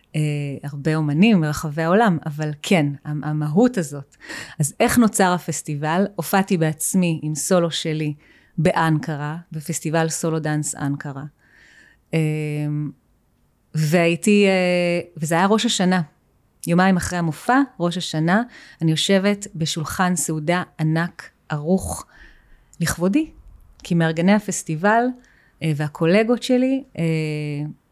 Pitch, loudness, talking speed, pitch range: 165 Hz, -20 LUFS, 105 wpm, 155-185 Hz